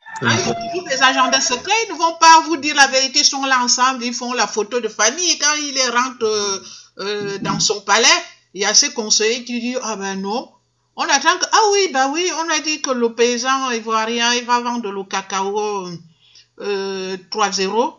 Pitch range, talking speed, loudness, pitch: 210-290 Hz, 210 wpm, -16 LUFS, 245 Hz